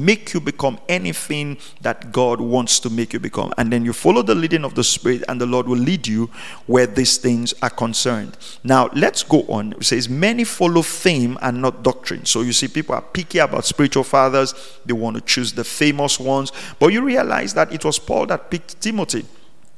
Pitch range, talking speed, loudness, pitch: 120-155 Hz, 210 wpm, -18 LUFS, 130 Hz